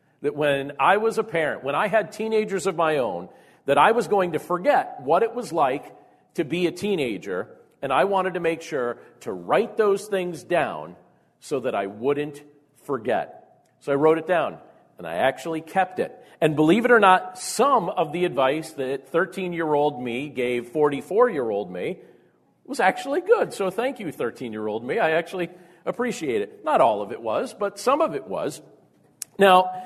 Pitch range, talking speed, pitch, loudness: 150-210 Hz, 195 wpm, 180 Hz, -23 LUFS